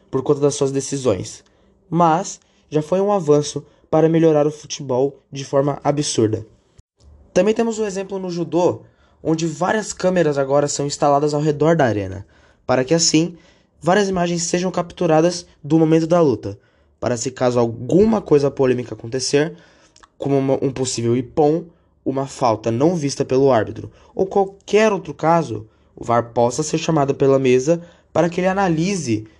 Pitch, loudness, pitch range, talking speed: 150 Hz, -19 LUFS, 130-170 Hz, 155 wpm